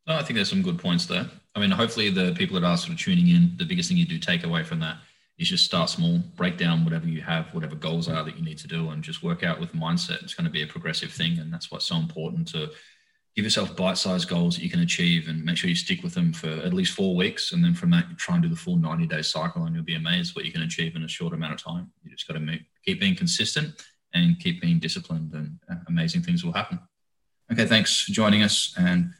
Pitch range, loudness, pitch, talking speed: 150-180 Hz, -25 LUFS, 170 Hz, 270 wpm